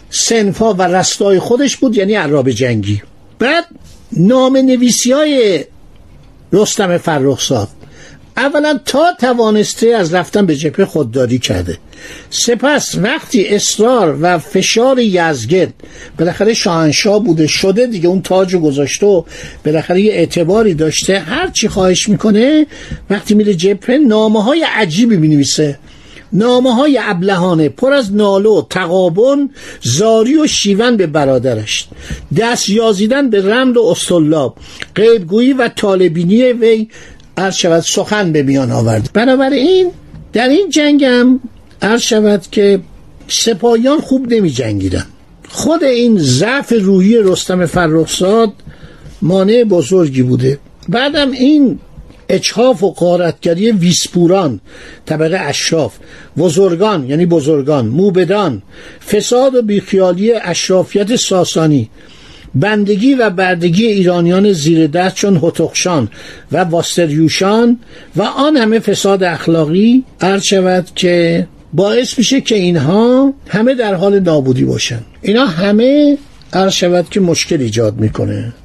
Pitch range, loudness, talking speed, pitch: 165-230 Hz, -11 LUFS, 115 wpm, 195 Hz